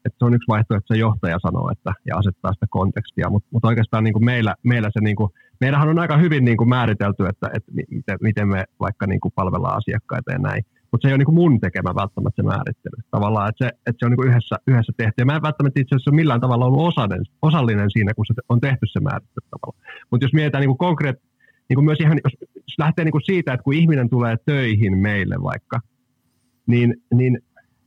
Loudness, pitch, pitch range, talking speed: -19 LUFS, 120 Hz, 110-135 Hz, 215 wpm